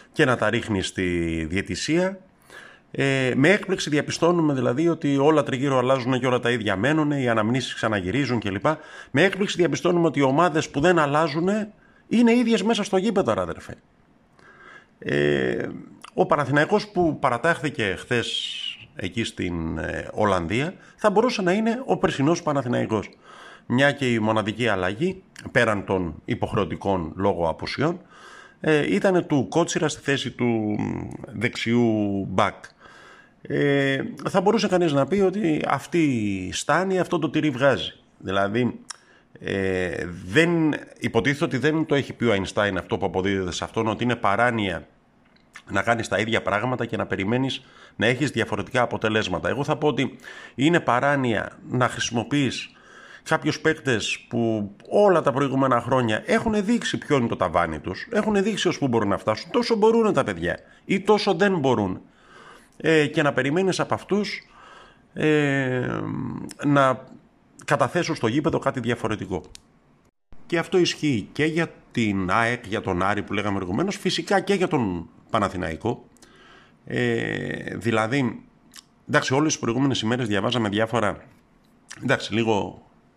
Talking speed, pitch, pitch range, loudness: 140 wpm, 130 Hz, 105-165 Hz, -23 LUFS